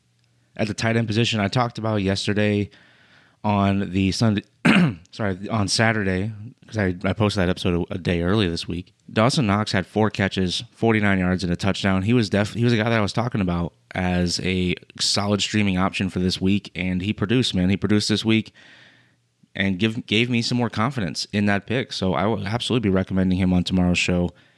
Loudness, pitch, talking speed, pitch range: -22 LUFS, 100 Hz, 205 wpm, 95-110 Hz